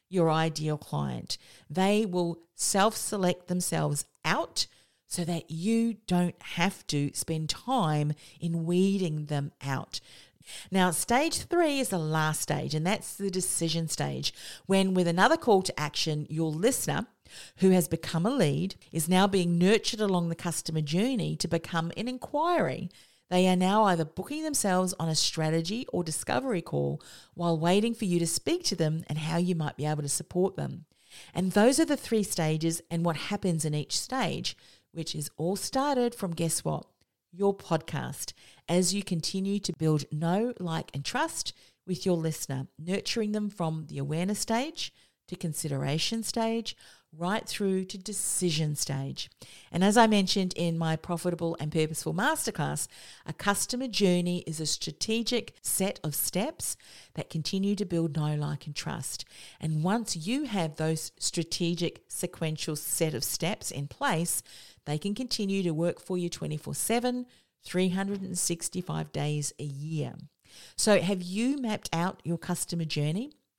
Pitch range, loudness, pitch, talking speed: 155-200 Hz, -29 LUFS, 170 Hz, 155 wpm